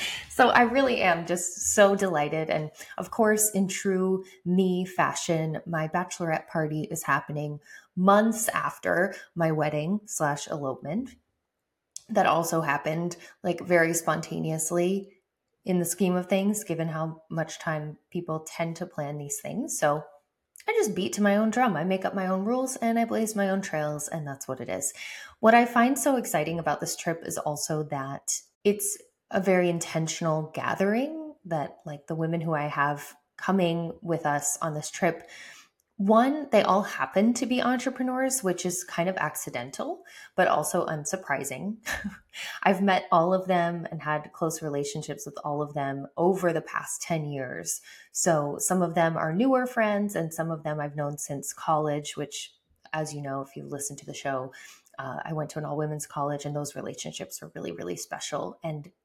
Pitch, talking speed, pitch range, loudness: 165 Hz, 175 wpm, 150-195 Hz, -27 LUFS